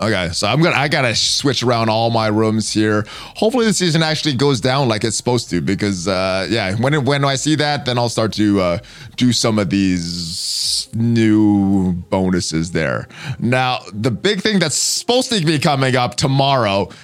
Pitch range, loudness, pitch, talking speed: 100-140 Hz, -16 LUFS, 115 Hz, 185 wpm